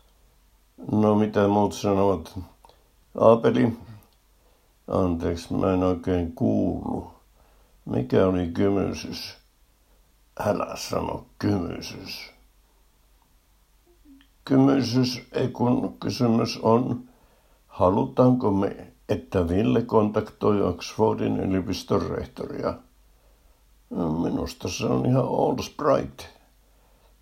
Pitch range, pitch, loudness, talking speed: 85-115 Hz, 100 Hz, -24 LUFS, 75 wpm